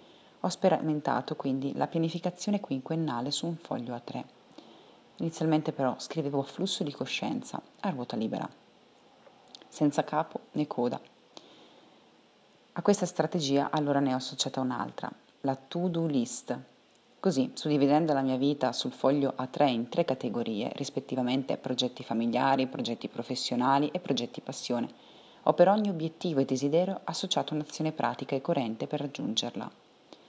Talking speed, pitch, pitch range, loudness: 135 wpm, 145 Hz, 130-165 Hz, -30 LUFS